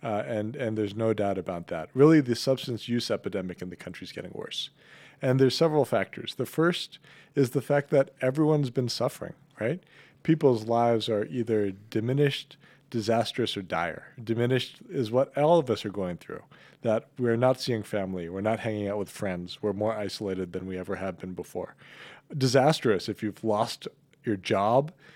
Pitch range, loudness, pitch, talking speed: 105-135 Hz, -28 LUFS, 115 Hz, 180 wpm